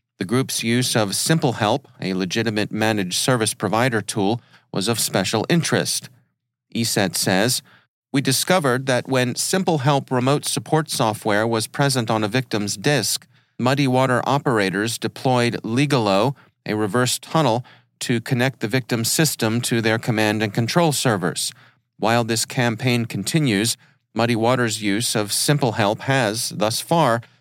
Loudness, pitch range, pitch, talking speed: -20 LUFS, 110-135 Hz, 120 Hz, 140 wpm